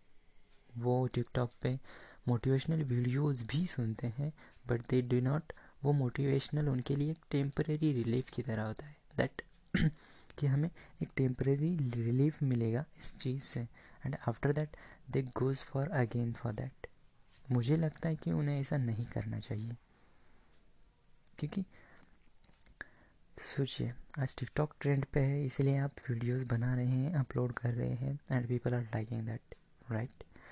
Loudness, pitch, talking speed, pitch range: -36 LUFS, 130 Hz, 145 wpm, 120-145 Hz